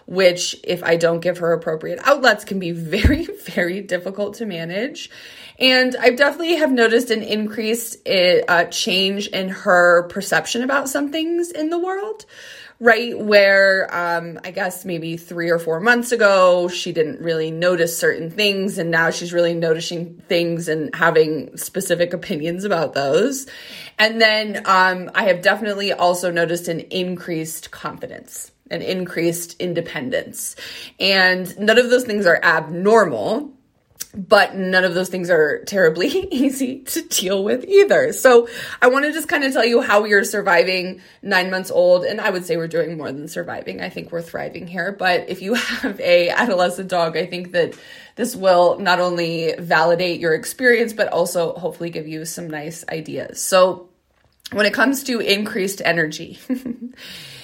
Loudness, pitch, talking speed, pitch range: -18 LUFS, 190 Hz, 165 wpm, 170-240 Hz